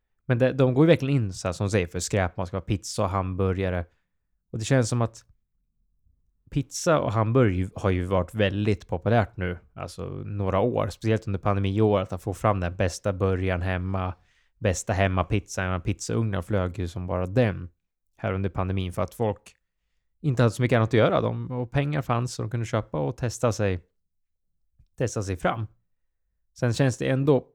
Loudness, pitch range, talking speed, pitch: -26 LUFS, 90-115 Hz, 190 wpm, 100 Hz